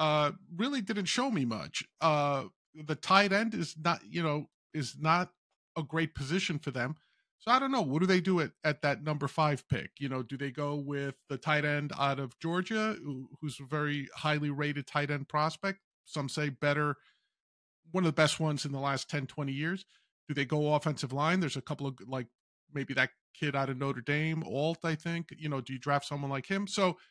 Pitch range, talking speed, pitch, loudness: 140-165 Hz, 220 wpm, 150 Hz, -32 LUFS